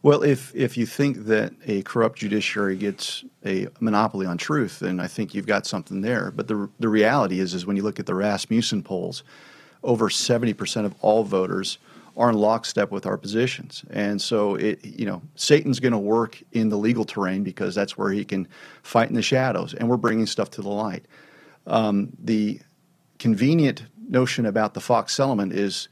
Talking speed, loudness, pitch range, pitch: 190 wpm, -23 LUFS, 100-125 Hz, 110 Hz